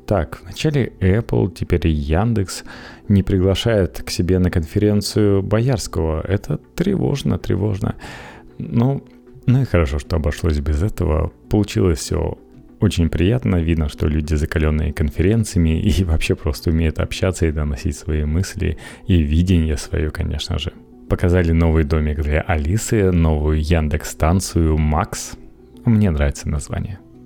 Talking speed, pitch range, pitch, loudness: 130 wpm, 80-100 Hz, 90 Hz, -19 LUFS